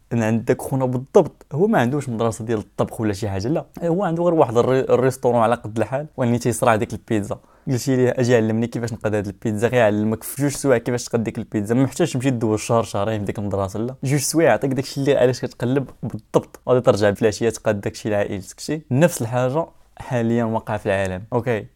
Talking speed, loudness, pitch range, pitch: 220 wpm, -21 LUFS, 110-130 Hz, 120 Hz